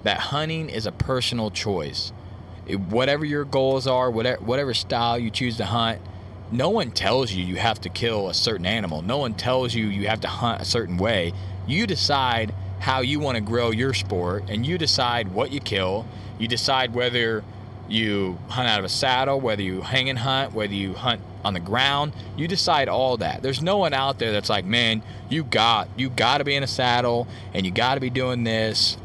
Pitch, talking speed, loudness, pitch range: 115 Hz, 215 wpm, -23 LUFS, 100-130 Hz